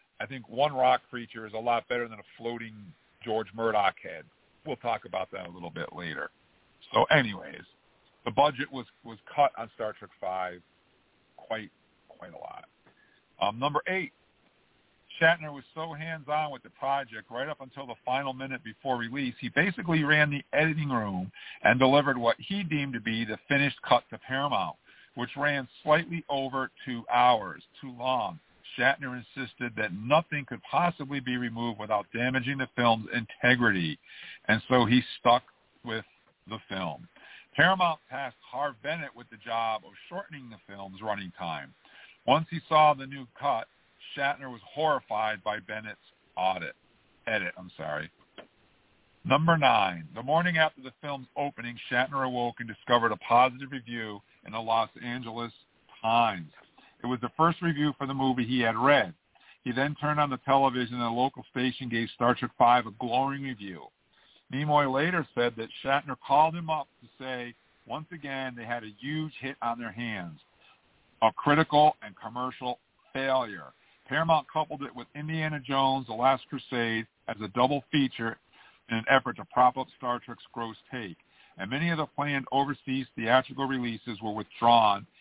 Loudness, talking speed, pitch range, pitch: -28 LUFS, 165 wpm, 115-140 Hz, 125 Hz